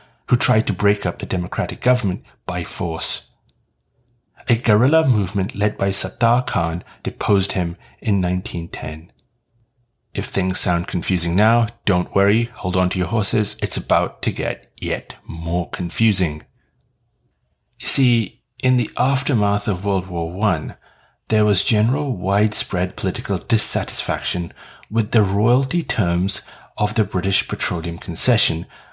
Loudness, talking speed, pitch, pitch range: -19 LUFS, 135 wpm, 105 Hz, 90-115 Hz